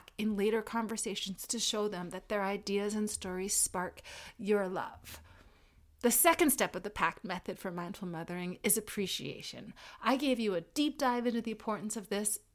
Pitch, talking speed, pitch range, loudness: 205 Hz, 175 wpm, 185-225 Hz, -33 LUFS